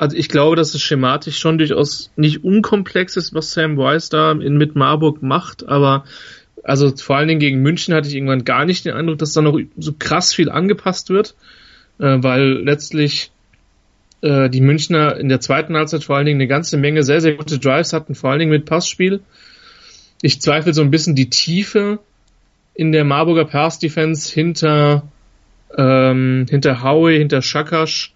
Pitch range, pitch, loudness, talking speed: 140-160 Hz, 150 Hz, -15 LUFS, 175 wpm